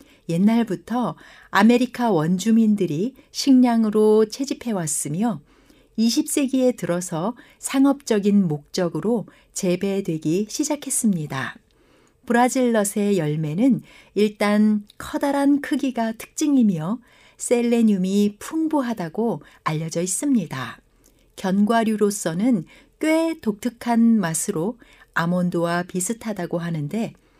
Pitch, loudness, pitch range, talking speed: 215 Hz, -21 LUFS, 180-245 Hz, 235 characters per minute